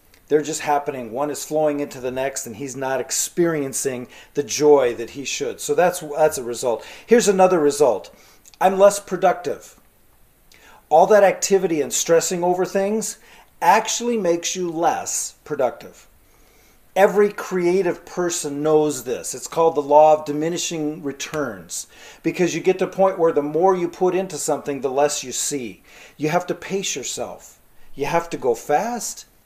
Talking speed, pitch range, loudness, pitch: 165 wpm, 145-185 Hz, -20 LUFS, 165 Hz